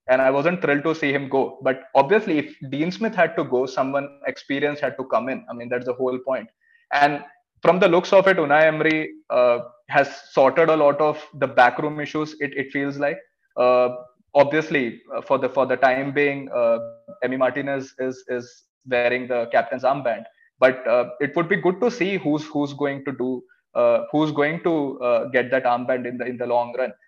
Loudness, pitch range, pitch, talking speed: -21 LUFS, 130-170 Hz, 145 Hz, 210 wpm